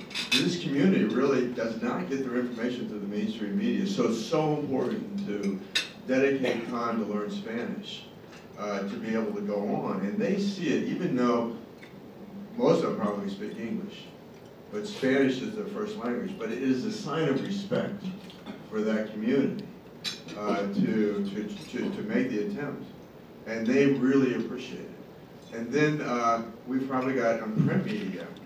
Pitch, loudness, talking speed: 130 Hz, -29 LUFS, 165 wpm